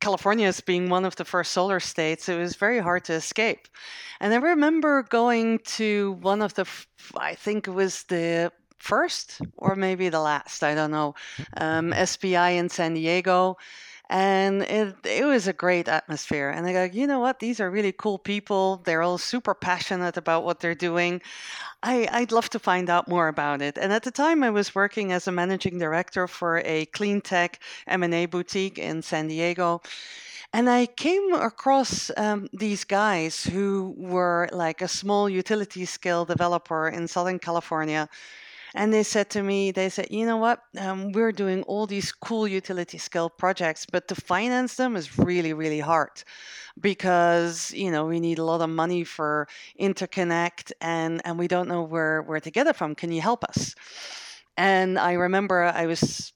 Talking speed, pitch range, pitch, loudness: 185 wpm, 170-205 Hz, 185 Hz, -25 LUFS